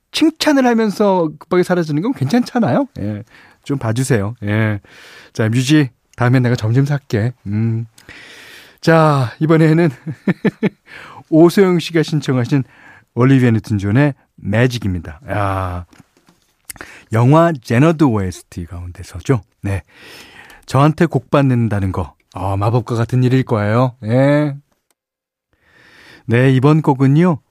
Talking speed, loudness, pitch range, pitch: 240 characters per minute, -15 LUFS, 110-155 Hz, 130 Hz